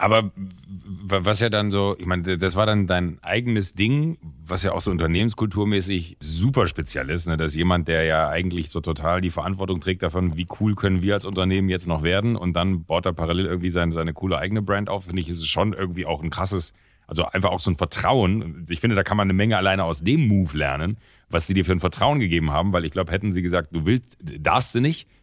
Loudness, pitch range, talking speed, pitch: -22 LUFS, 85-100 Hz, 235 wpm, 95 Hz